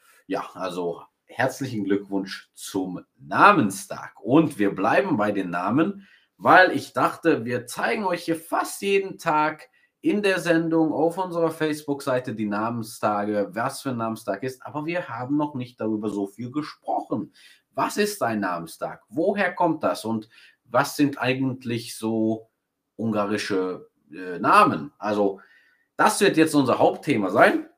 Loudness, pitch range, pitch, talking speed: -24 LUFS, 105-160 Hz, 125 Hz, 145 wpm